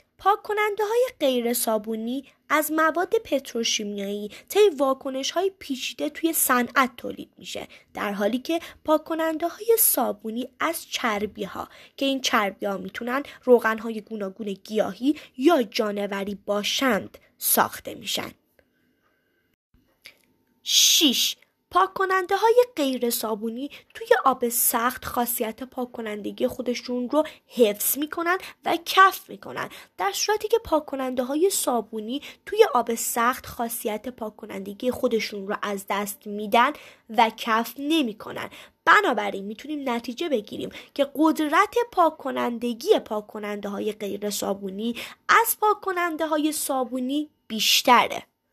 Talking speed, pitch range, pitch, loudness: 110 wpm, 220-320 Hz, 255 Hz, -24 LUFS